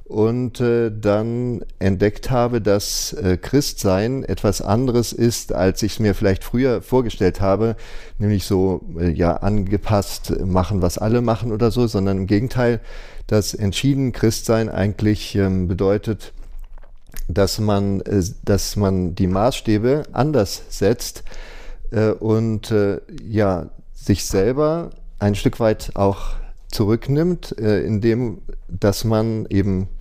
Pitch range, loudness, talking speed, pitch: 95-115 Hz, -20 LUFS, 130 wpm, 105 Hz